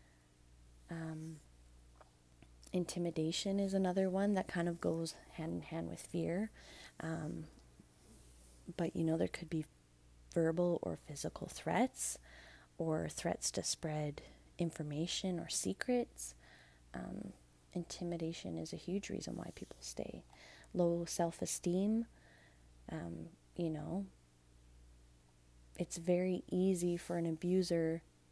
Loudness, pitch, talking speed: -39 LUFS, 160 Hz, 110 wpm